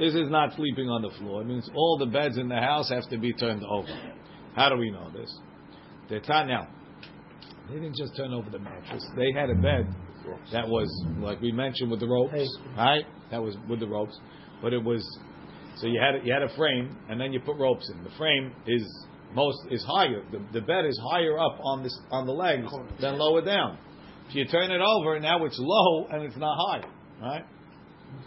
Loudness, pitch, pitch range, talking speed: -27 LUFS, 125 Hz, 110-150 Hz, 215 wpm